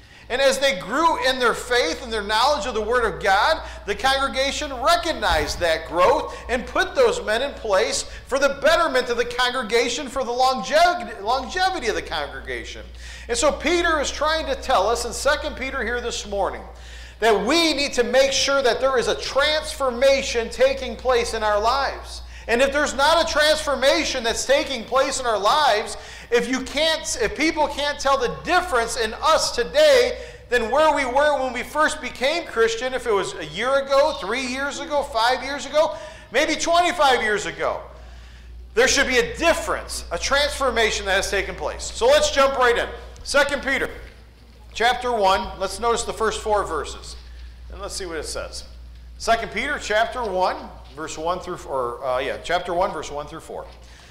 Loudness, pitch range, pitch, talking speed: -21 LUFS, 215-290 Hz, 255 Hz, 185 wpm